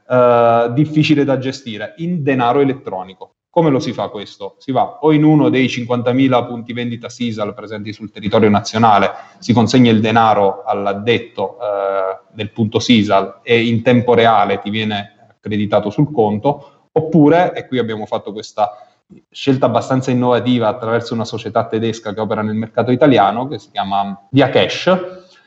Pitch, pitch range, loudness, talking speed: 115 Hz, 105-130 Hz, -15 LUFS, 160 wpm